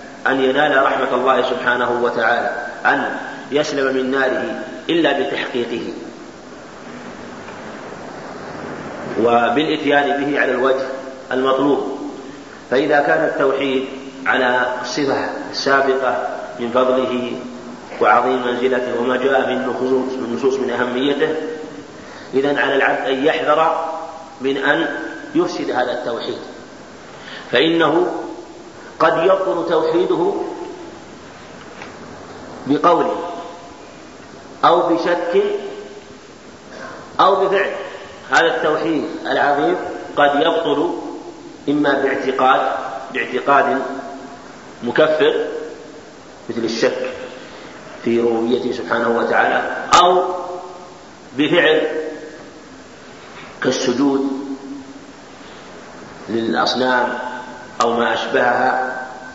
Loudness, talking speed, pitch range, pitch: -17 LUFS, 75 wpm, 130-160 Hz, 135 Hz